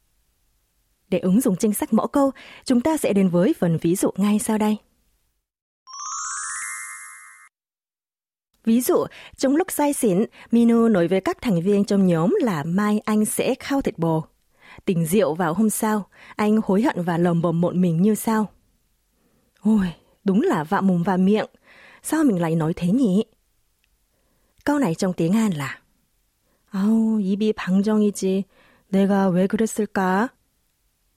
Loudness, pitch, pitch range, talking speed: -21 LUFS, 205 Hz, 175-225 Hz, 155 wpm